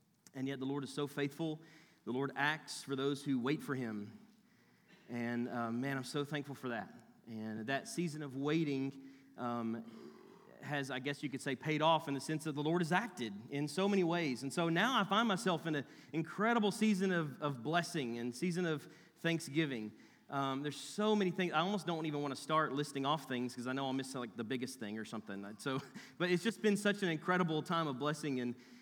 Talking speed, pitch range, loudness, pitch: 220 wpm, 130-165 Hz, -38 LUFS, 145 Hz